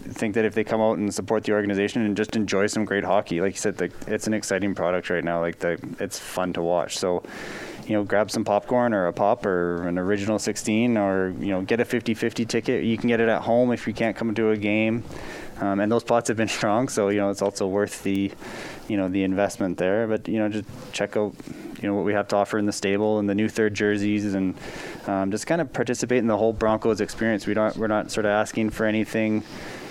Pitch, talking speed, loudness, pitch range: 105 Hz, 245 wpm, -24 LUFS, 100-110 Hz